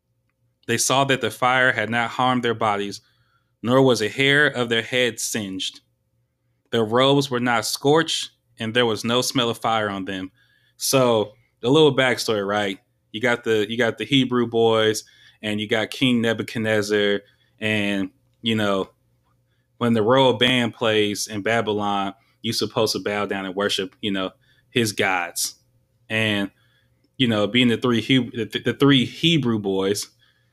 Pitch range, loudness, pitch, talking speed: 105-125 Hz, -21 LUFS, 115 Hz, 165 wpm